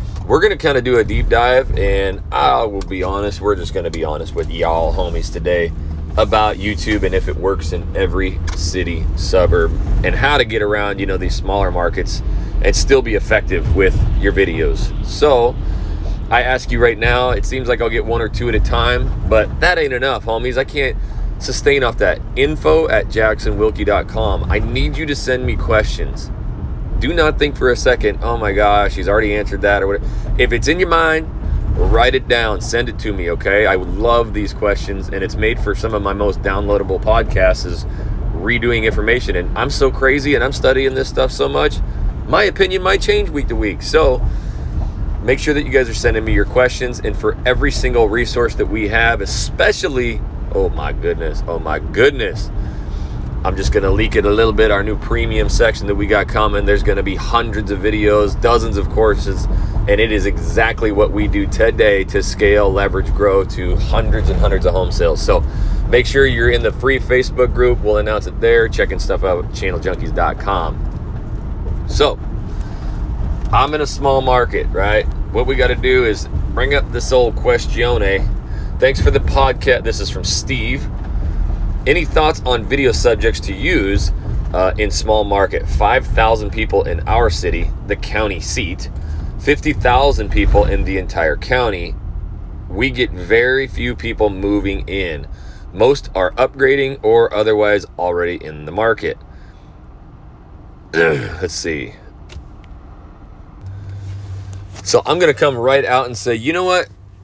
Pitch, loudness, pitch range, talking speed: 105 Hz, -16 LUFS, 90-115 Hz, 180 wpm